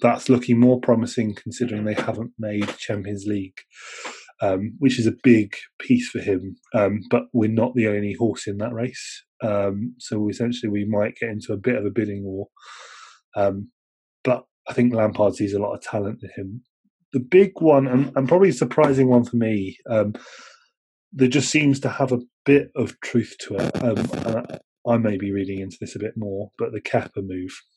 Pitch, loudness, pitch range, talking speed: 115 Hz, -22 LUFS, 105-125 Hz, 200 wpm